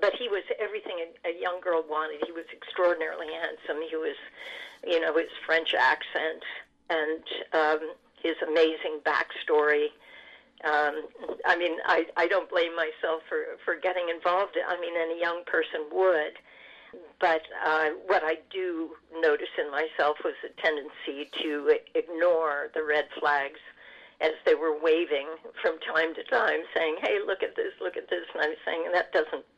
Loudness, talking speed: -28 LUFS, 160 wpm